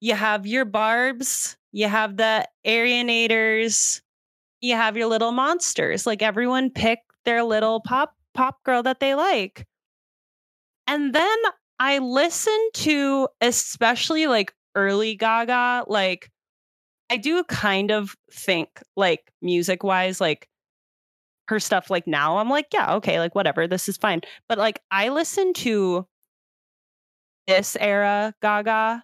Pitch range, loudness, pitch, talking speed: 205-260 Hz, -22 LUFS, 225 Hz, 130 wpm